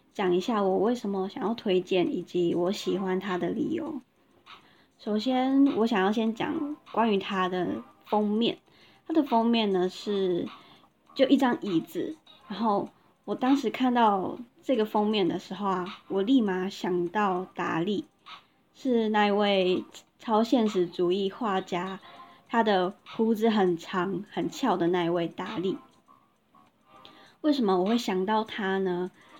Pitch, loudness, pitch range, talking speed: 200 Hz, -27 LUFS, 185-230 Hz, 205 characters per minute